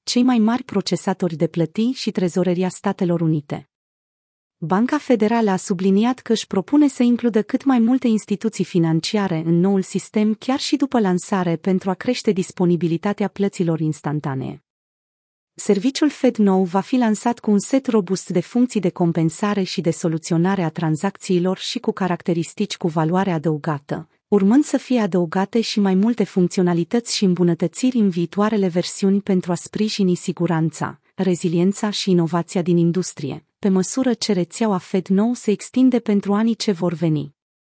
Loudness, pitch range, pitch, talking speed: -20 LUFS, 175-220 Hz, 190 Hz, 150 wpm